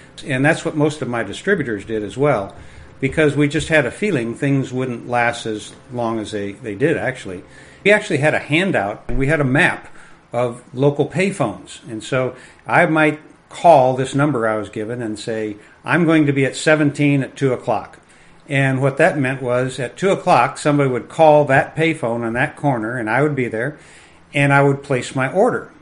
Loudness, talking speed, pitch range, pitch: -18 LUFS, 200 wpm, 120-150 Hz, 135 Hz